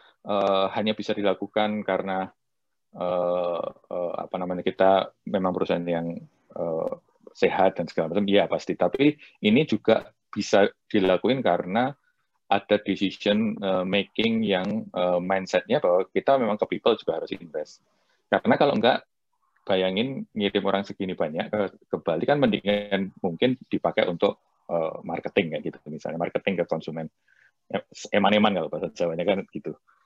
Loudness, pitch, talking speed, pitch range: -25 LUFS, 100 Hz, 140 wpm, 95-110 Hz